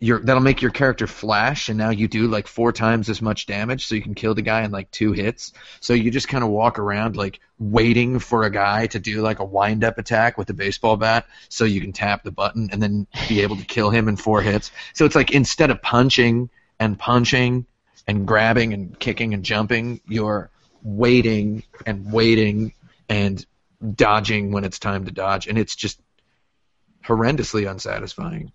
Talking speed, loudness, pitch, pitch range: 200 wpm, -20 LUFS, 110 Hz, 105-120 Hz